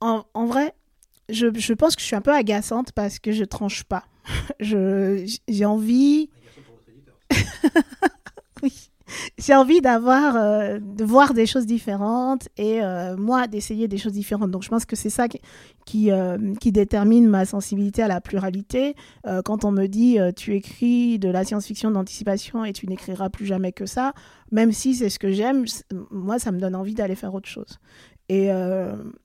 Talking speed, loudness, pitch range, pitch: 185 wpm, -22 LUFS, 195-235 Hz, 215 Hz